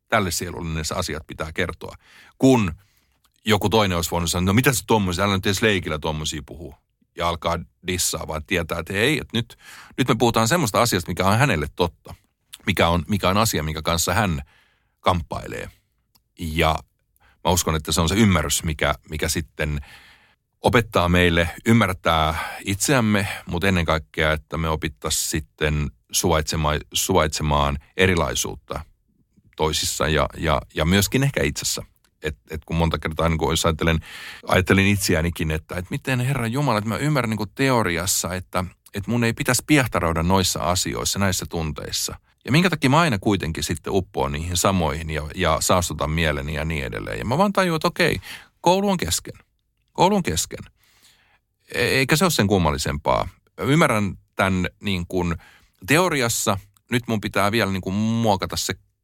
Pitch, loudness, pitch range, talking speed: 90 Hz, -21 LUFS, 80-105 Hz, 160 wpm